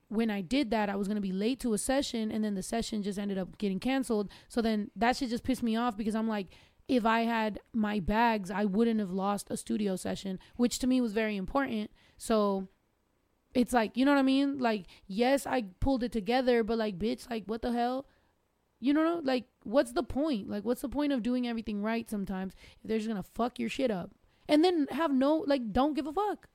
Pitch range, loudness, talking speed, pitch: 210-260 Hz, -31 LUFS, 235 wpm, 230 Hz